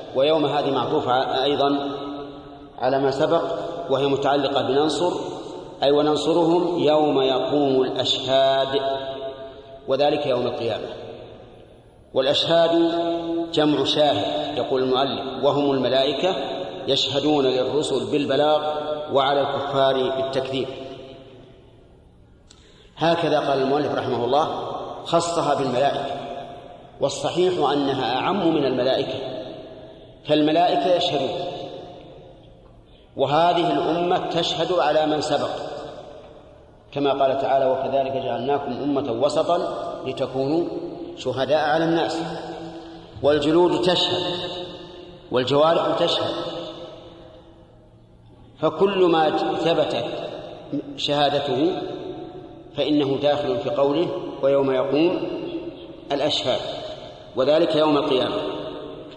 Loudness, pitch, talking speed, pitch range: -22 LUFS, 145 Hz, 80 wpm, 135-165 Hz